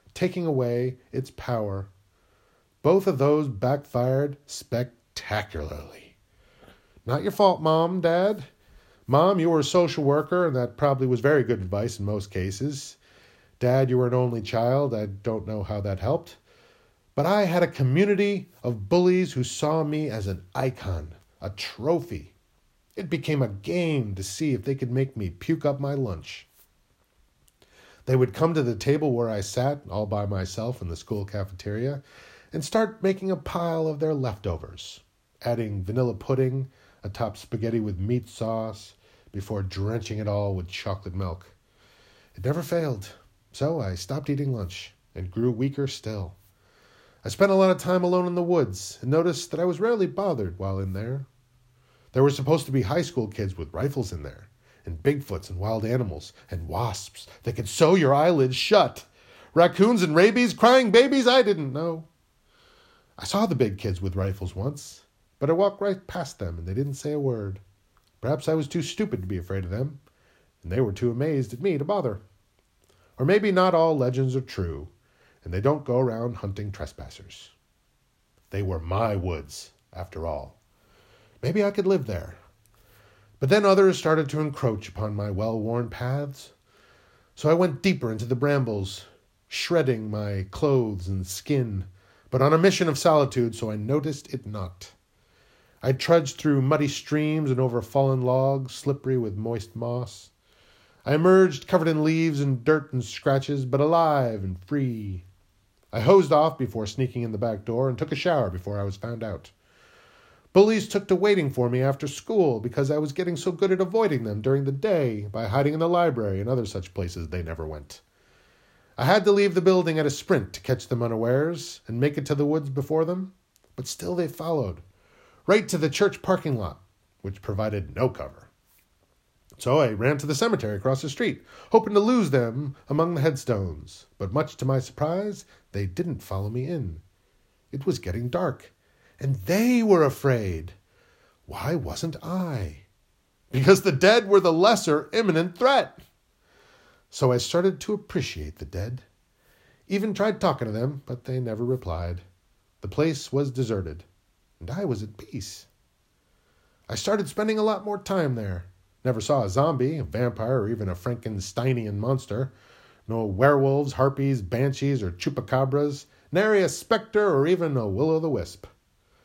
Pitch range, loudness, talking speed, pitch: 100-155 Hz, -25 LUFS, 175 wpm, 130 Hz